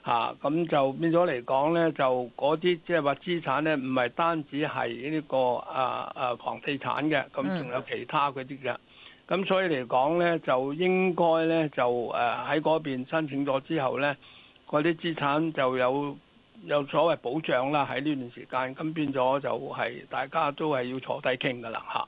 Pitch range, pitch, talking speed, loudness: 130-165 Hz, 145 Hz, 260 characters per minute, -28 LUFS